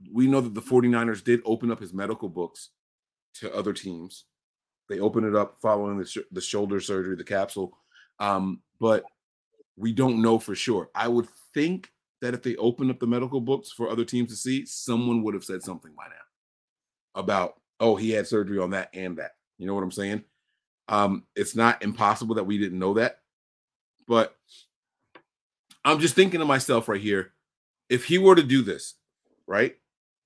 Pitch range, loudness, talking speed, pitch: 100-125 Hz, -25 LUFS, 185 wpm, 110 Hz